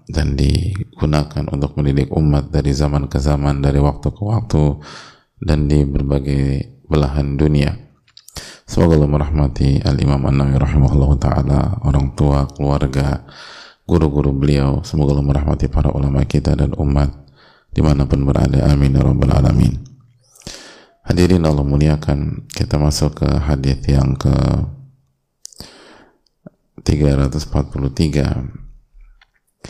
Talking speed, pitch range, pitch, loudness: 110 wpm, 70-75 Hz, 70 Hz, -16 LUFS